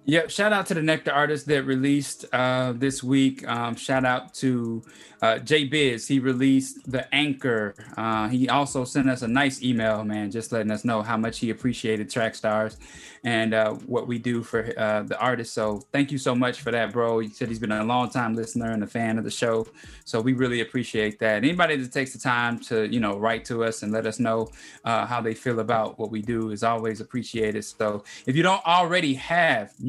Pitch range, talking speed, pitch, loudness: 110-135 Hz, 220 wpm, 120 Hz, -25 LUFS